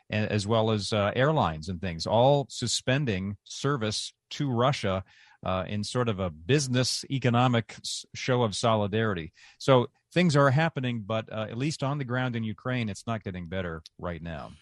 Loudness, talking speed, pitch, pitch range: -28 LUFS, 170 wpm, 115 Hz, 100-130 Hz